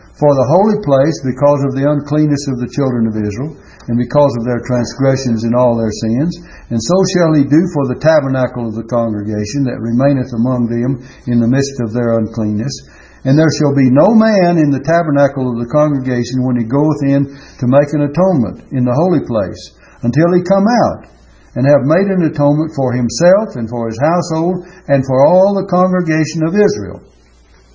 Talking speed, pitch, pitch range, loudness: 190 wpm, 140 Hz, 120-155 Hz, -13 LUFS